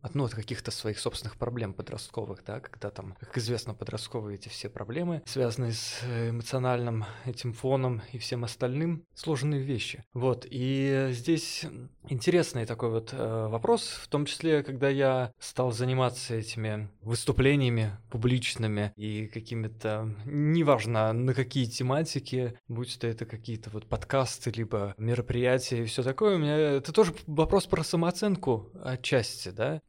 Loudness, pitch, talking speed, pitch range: -30 LUFS, 125 Hz, 145 wpm, 115-135 Hz